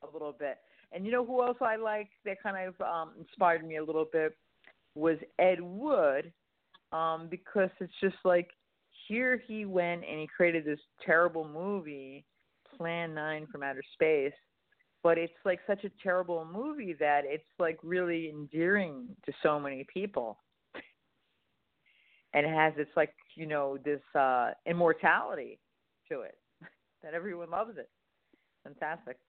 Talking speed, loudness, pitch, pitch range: 150 wpm, -32 LUFS, 170 Hz, 155-195 Hz